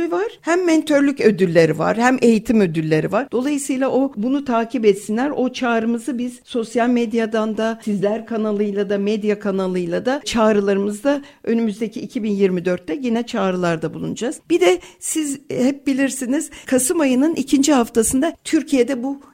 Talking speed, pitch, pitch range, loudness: 135 wpm, 235 Hz, 210-275 Hz, -19 LUFS